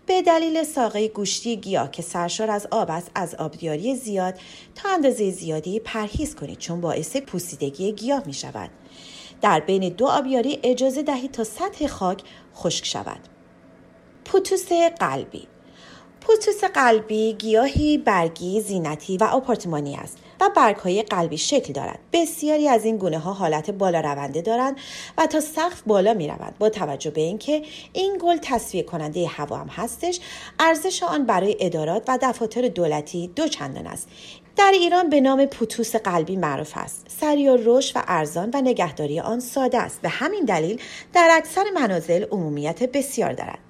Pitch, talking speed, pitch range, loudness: 225 Hz, 155 wpm, 175-285 Hz, -22 LUFS